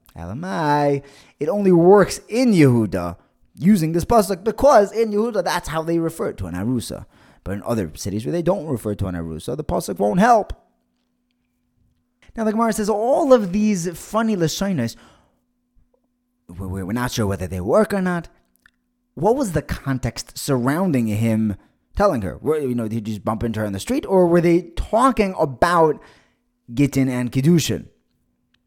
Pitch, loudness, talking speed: 140 Hz, -20 LUFS, 170 wpm